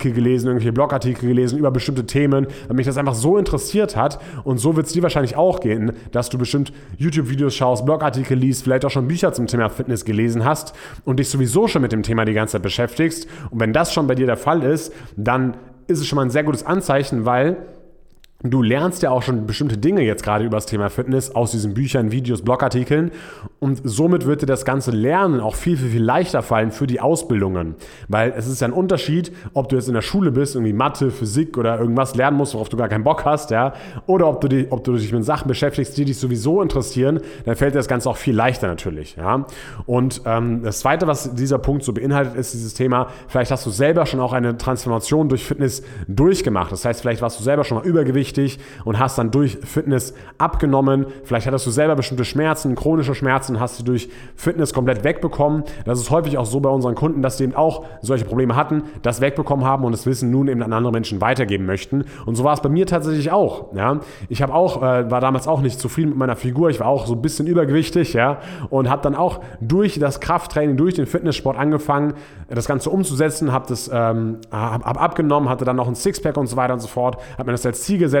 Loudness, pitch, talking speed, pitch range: -19 LUFS, 130 Hz, 230 wpm, 120-150 Hz